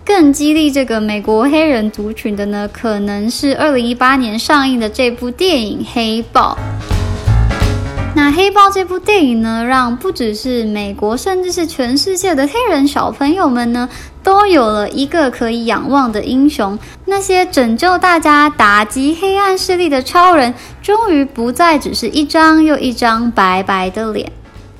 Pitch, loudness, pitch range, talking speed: 260 Hz, -12 LUFS, 220-320 Hz, 240 characters per minute